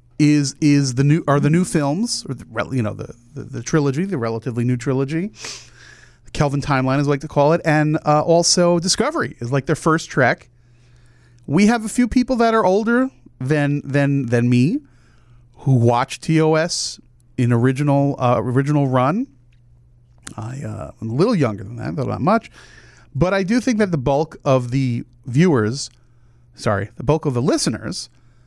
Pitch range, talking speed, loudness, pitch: 120-160 Hz, 175 wpm, -19 LUFS, 140 Hz